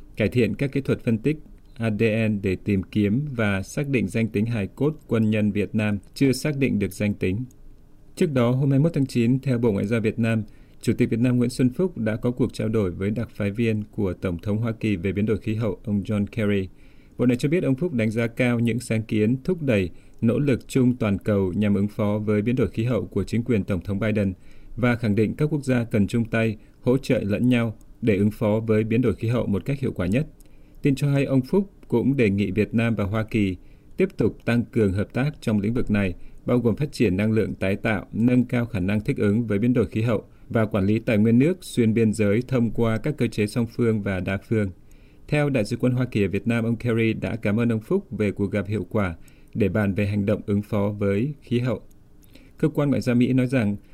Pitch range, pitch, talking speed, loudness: 105-125 Hz, 115 Hz, 255 wpm, -23 LUFS